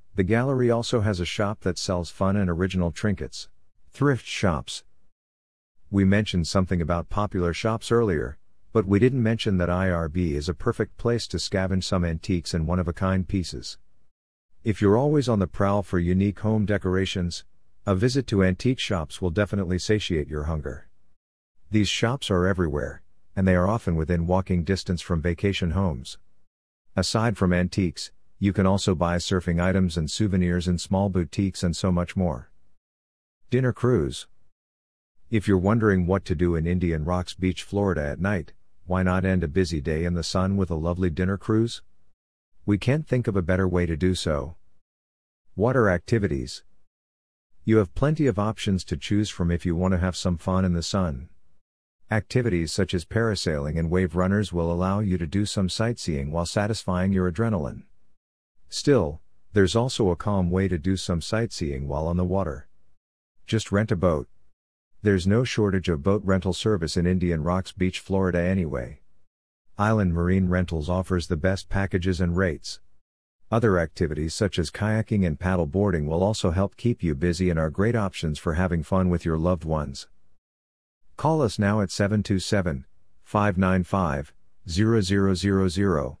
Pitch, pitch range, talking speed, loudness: 95 Hz, 85-100 Hz, 165 wpm, -25 LUFS